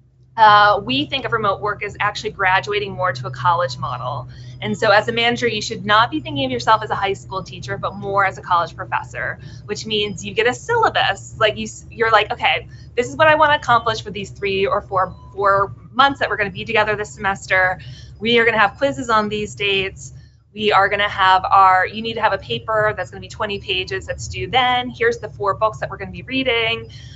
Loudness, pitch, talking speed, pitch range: -18 LUFS, 205 Hz, 245 wpm, 185-230 Hz